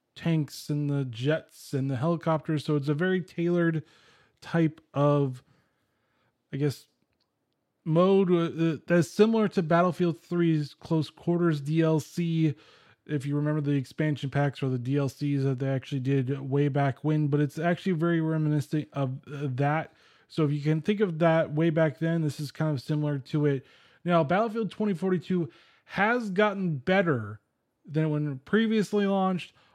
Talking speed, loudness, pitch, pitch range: 150 wpm, -27 LUFS, 155 Hz, 145-170 Hz